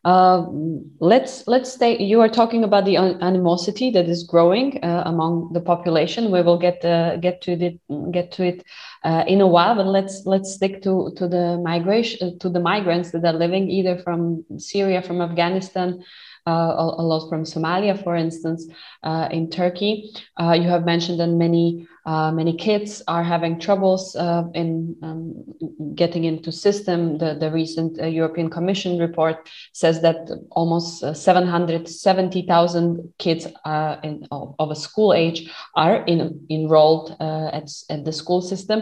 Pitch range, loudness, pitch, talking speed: 165-185 Hz, -20 LUFS, 170 Hz, 165 wpm